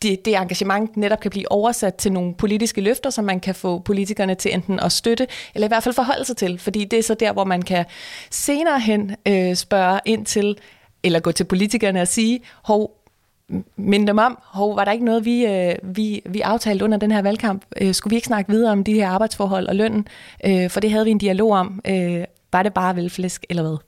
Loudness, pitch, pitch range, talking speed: -20 LUFS, 205 Hz, 190-220 Hz, 230 wpm